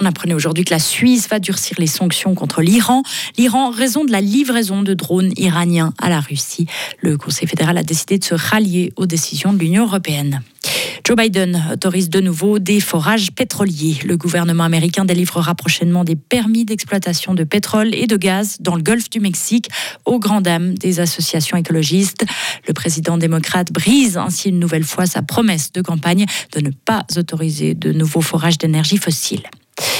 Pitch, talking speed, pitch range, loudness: 180 Hz, 180 wpm, 165-205 Hz, -16 LUFS